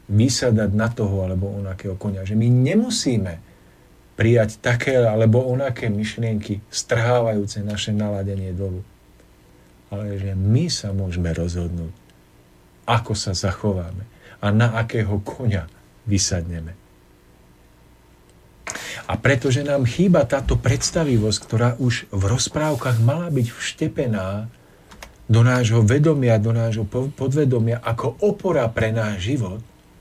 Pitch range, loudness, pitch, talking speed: 95-125 Hz, -21 LUFS, 110 Hz, 110 wpm